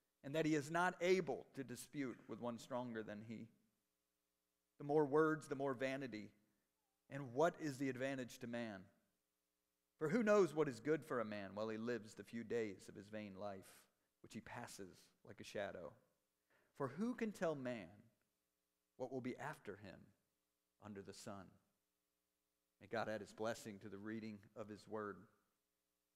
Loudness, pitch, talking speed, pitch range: -44 LUFS, 110 Hz, 170 wpm, 95-135 Hz